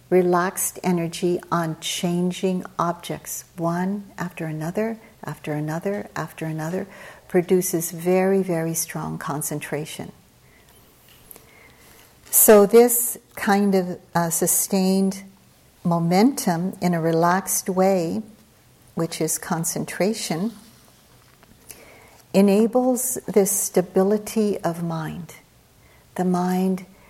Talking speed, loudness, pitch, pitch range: 85 wpm, -22 LUFS, 180 Hz, 165-195 Hz